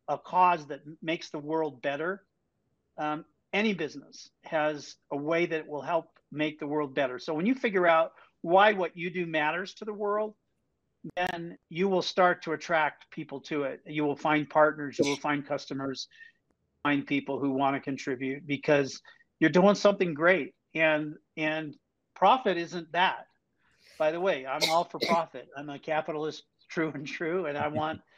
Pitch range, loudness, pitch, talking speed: 145-175 Hz, -29 LUFS, 155 Hz, 175 wpm